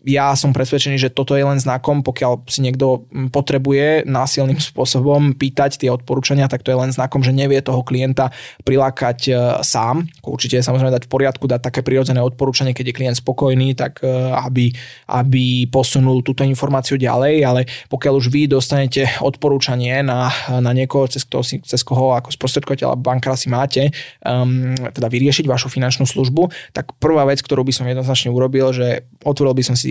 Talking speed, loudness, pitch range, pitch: 175 wpm, -16 LUFS, 125-140 Hz, 130 Hz